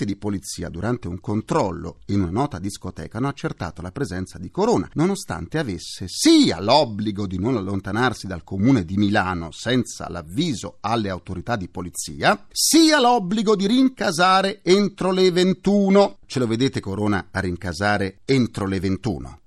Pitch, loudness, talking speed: 105 Hz, -21 LUFS, 150 wpm